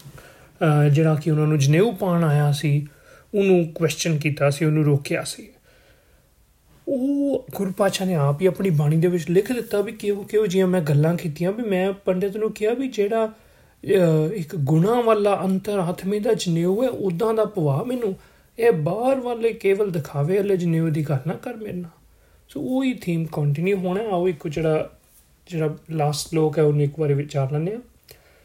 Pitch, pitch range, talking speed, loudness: 180 Hz, 155-205 Hz, 175 wpm, -22 LUFS